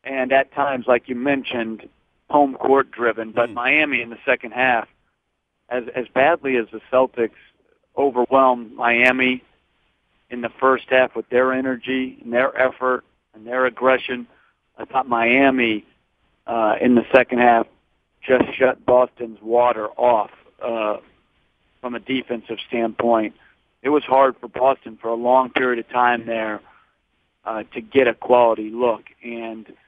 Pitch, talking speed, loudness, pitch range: 125 Hz, 145 wpm, -19 LUFS, 115-130 Hz